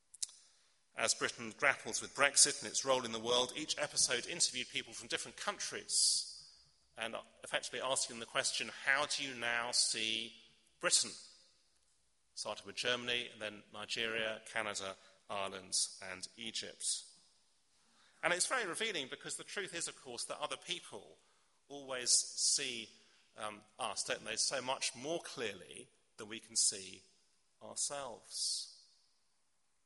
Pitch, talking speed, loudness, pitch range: 120 Hz, 135 wpm, -36 LUFS, 110-135 Hz